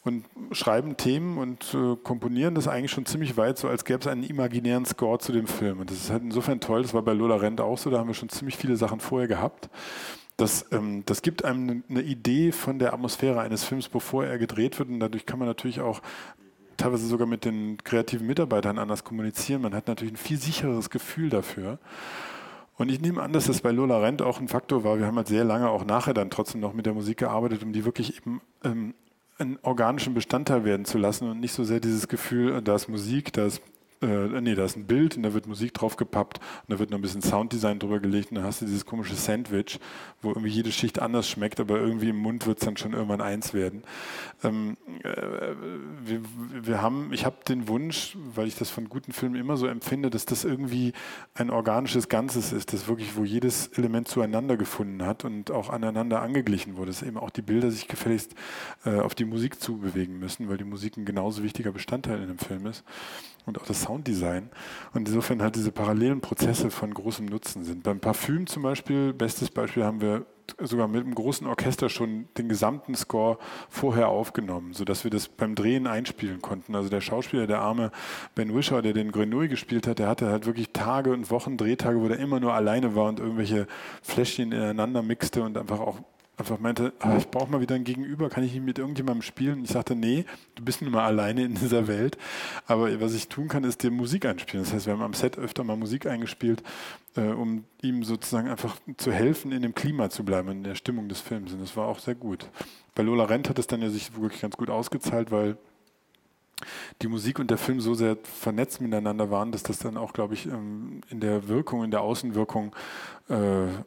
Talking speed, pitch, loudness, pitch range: 220 wpm, 115 Hz, -28 LUFS, 105-125 Hz